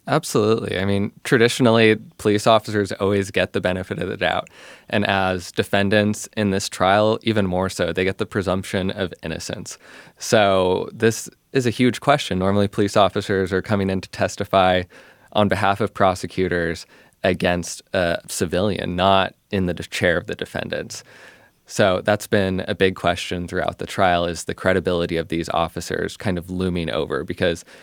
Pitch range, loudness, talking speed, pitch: 90-105 Hz, -21 LUFS, 165 wpm, 95 Hz